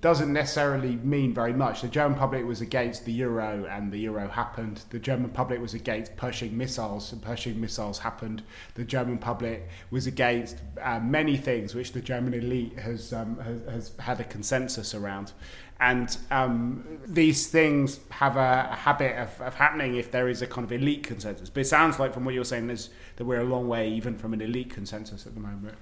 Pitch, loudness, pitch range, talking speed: 120 Hz, -28 LUFS, 110-130 Hz, 205 wpm